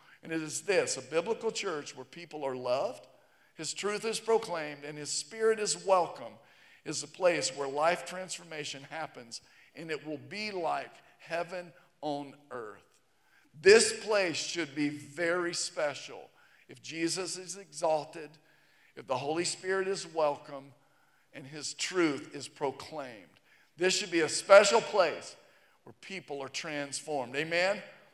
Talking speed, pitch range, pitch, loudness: 145 wpm, 145-190 Hz, 165 Hz, -31 LUFS